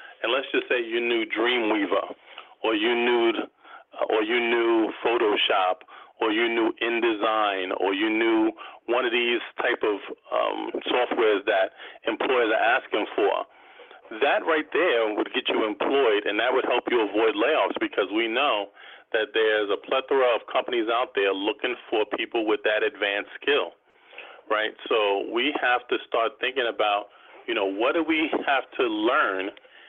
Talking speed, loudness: 165 wpm, -24 LUFS